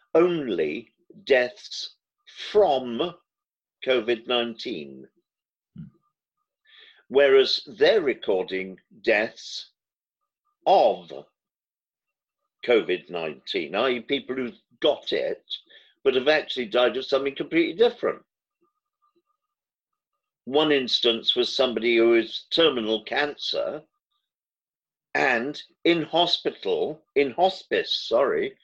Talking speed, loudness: 80 wpm, -24 LUFS